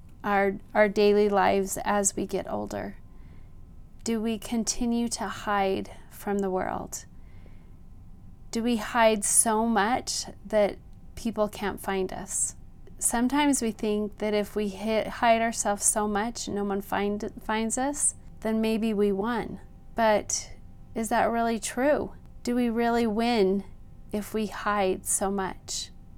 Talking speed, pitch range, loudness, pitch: 140 wpm, 185-225 Hz, -27 LUFS, 205 Hz